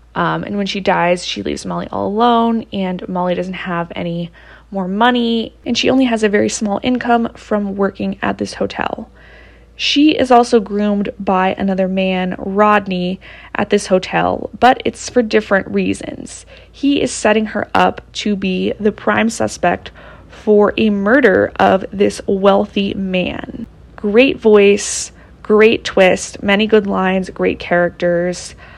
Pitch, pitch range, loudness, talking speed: 205 Hz, 185-225 Hz, -15 LUFS, 150 wpm